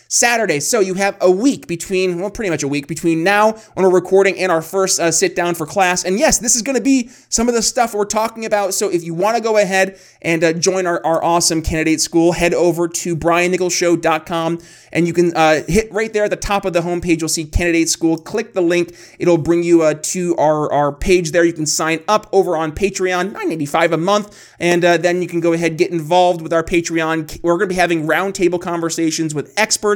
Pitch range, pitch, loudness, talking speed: 165-195 Hz, 175 Hz, -16 LUFS, 235 wpm